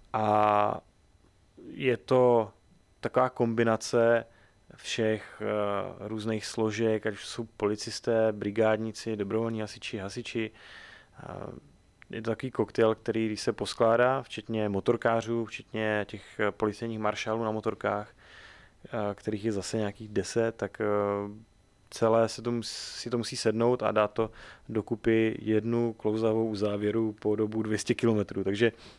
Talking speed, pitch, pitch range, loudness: 115 wpm, 110 Hz, 105-115 Hz, -29 LUFS